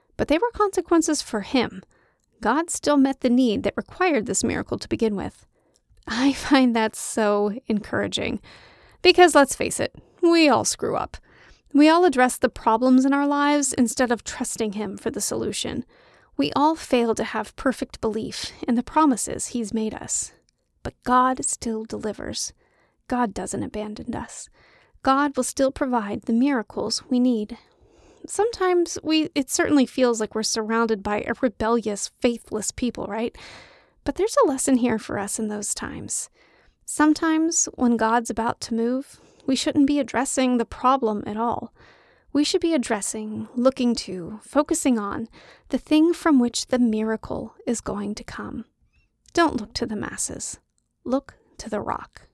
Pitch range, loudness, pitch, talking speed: 225-290 Hz, -23 LUFS, 250 Hz, 160 wpm